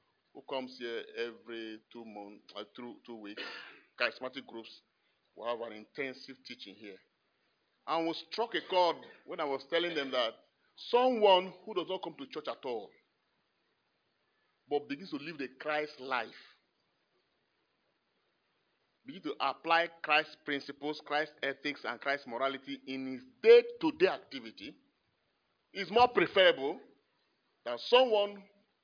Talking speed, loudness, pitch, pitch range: 135 wpm, -32 LUFS, 140 Hz, 125-175 Hz